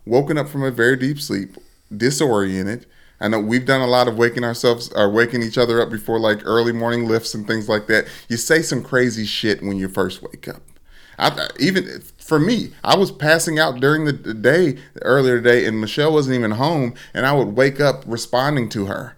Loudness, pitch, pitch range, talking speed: -18 LUFS, 120 Hz, 110-135 Hz, 215 wpm